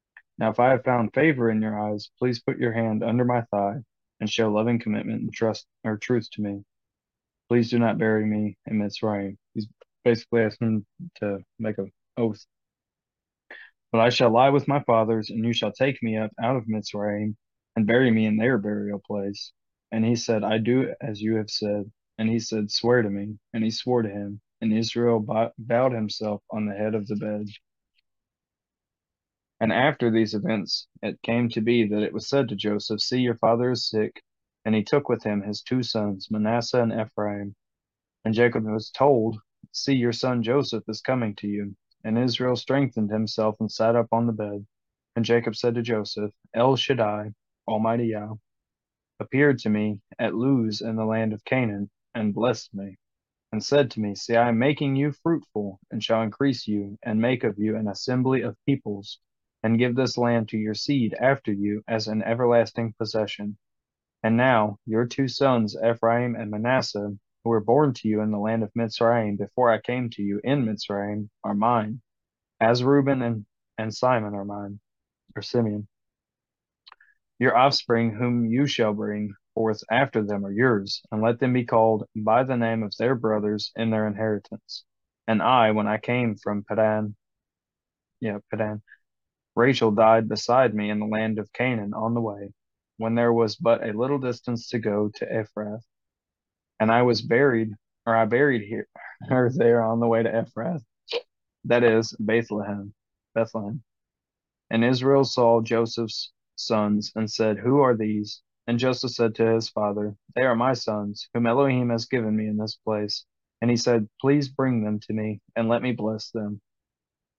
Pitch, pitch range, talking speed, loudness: 110 Hz, 105-120 Hz, 180 wpm, -24 LUFS